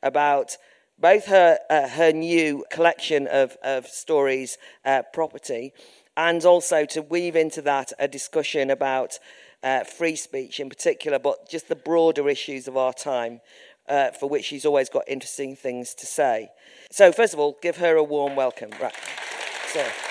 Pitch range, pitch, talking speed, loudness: 135-165 Hz, 145 Hz, 165 wpm, -23 LUFS